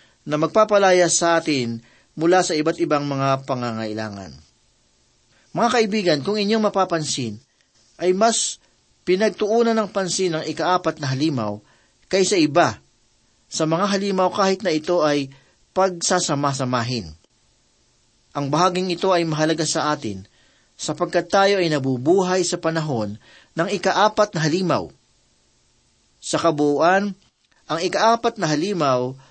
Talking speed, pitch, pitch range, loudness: 115 wpm, 165 Hz, 135-190 Hz, -20 LUFS